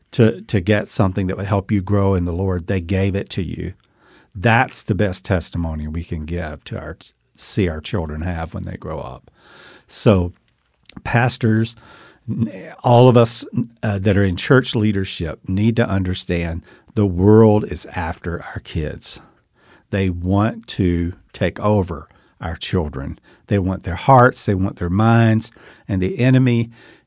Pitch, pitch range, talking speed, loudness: 100 Hz, 90-110 Hz, 160 wpm, -19 LUFS